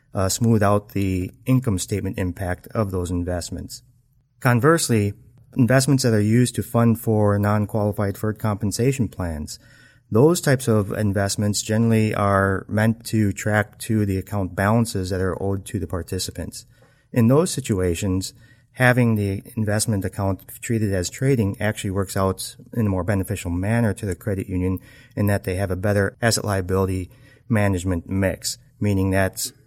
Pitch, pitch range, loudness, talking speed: 105 Hz, 95-120 Hz, -22 LUFS, 150 wpm